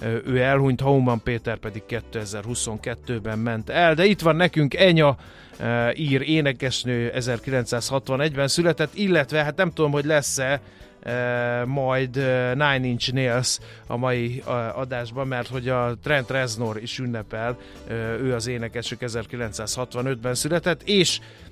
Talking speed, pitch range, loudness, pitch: 120 wpm, 120-140 Hz, -23 LUFS, 125 Hz